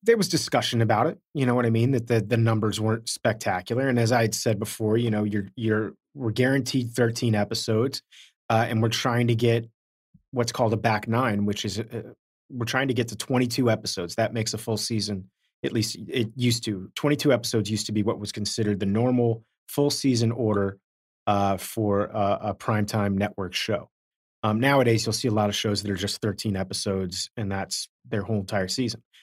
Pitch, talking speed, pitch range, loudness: 115 Hz, 210 wpm, 105-120 Hz, -25 LUFS